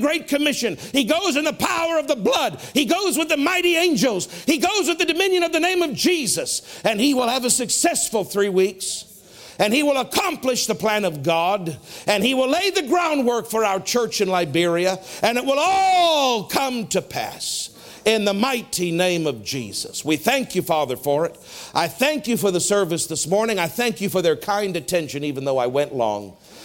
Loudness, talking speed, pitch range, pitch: -20 LUFS, 205 wpm, 180-295 Hz, 225 Hz